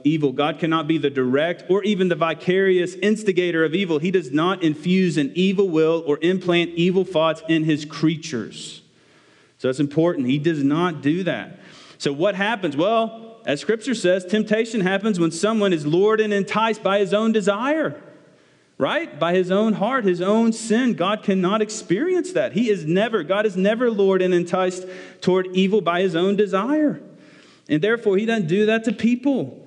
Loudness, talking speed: -20 LUFS, 180 wpm